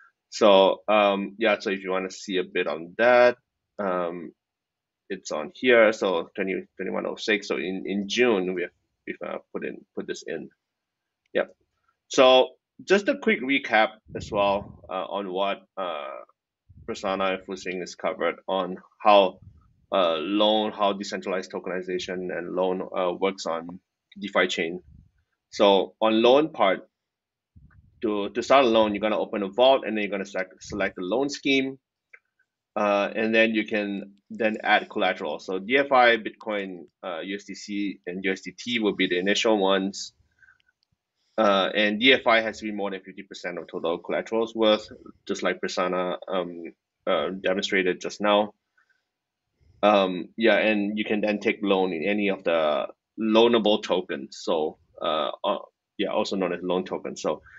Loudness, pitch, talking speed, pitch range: -24 LUFS, 100 Hz, 160 wpm, 95-110 Hz